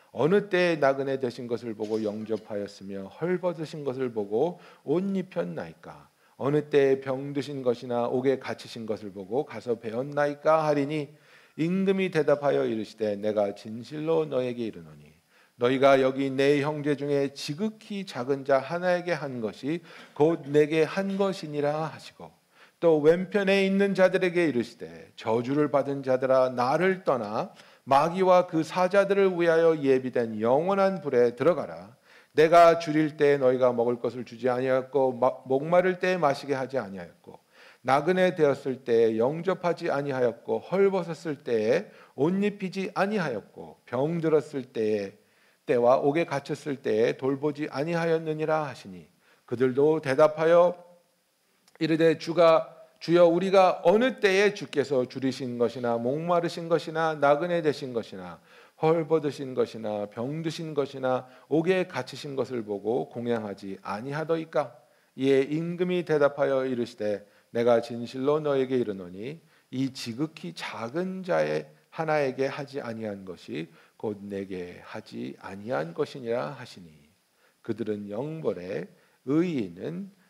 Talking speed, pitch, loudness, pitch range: 305 characters per minute, 145 Hz, -26 LUFS, 125-165 Hz